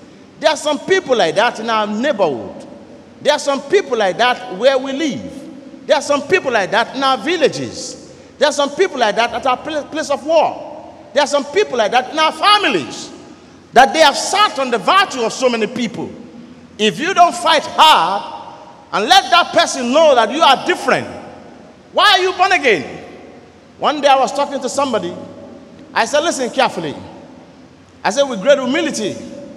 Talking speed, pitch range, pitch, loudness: 190 wpm, 260-320 Hz, 285 Hz, -14 LUFS